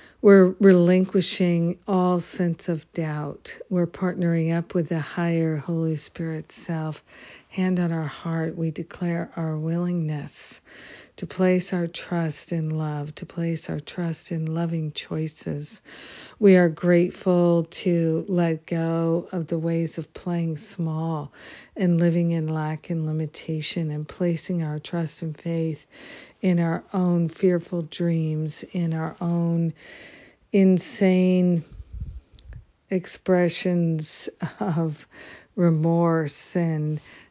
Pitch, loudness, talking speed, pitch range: 170 Hz, -24 LUFS, 115 wpm, 160-175 Hz